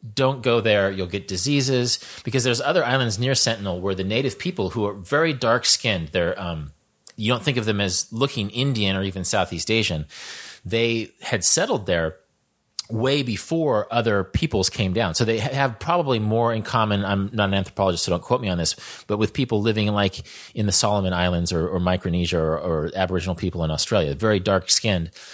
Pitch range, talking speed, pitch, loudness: 90-120 Hz, 190 wpm, 105 Hz, -22 LUFS